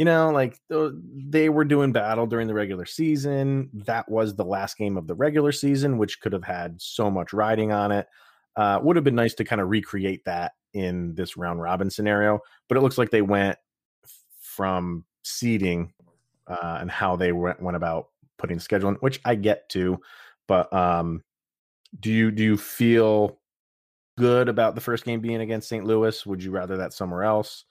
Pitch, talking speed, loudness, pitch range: 105 Hz, 195 wpm, -24 LUFS, 90-120 Hz